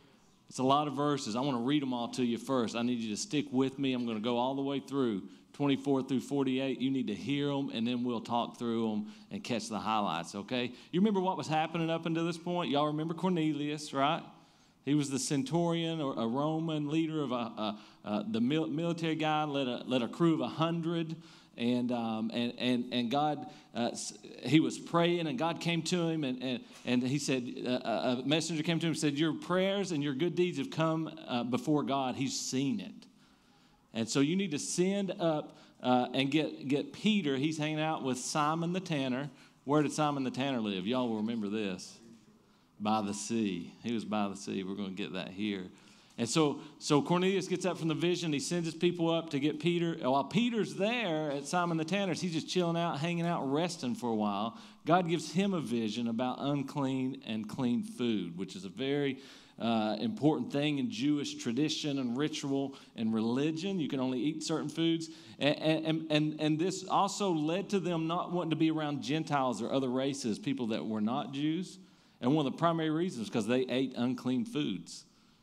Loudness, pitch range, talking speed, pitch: -33 LUFS, 125-165 Hz, 215 wpm, 145 Hz